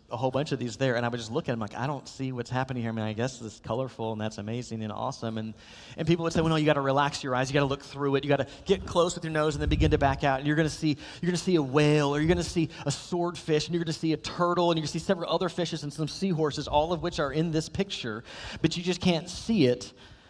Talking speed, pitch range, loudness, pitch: 335 wpm, 125-165 Hz, -28 LUFS, 145 Hz